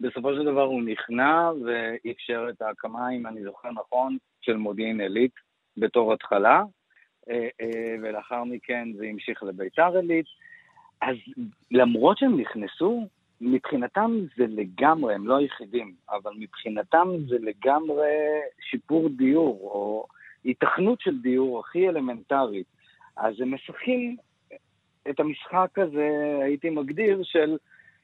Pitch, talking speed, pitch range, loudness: 130 Hz, 115 wpm, 115-165 Hz, -26 LUFS